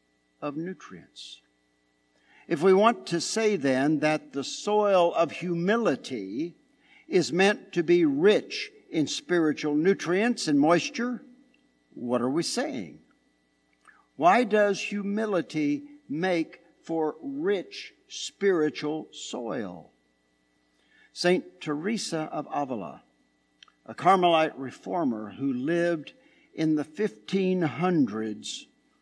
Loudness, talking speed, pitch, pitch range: -27 LUFS, 95 wpm, 170 Hz, 140-225 Hz